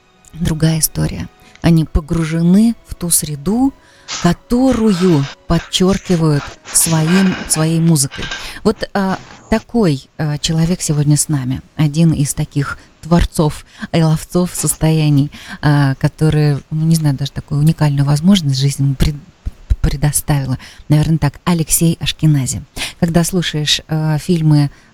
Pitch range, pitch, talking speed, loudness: 145-175 Hz, 155 Hz, 110 wpm, -15 LUFS